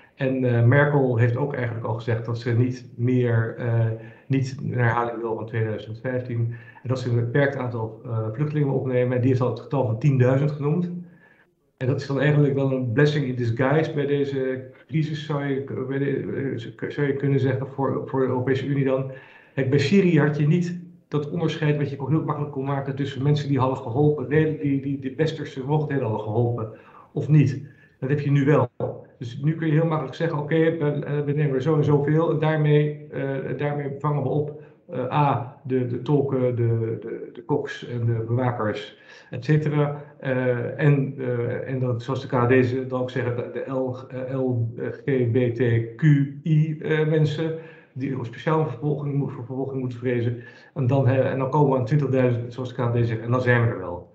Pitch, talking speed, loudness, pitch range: 135 Hz, 205 wpm, -24 LUFS, 125-145 Hz